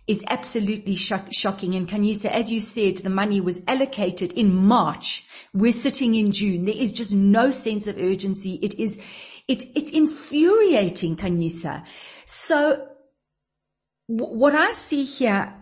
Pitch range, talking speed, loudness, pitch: 195-265 Hz, 150 wpm, -21 LUFS, 215 Hz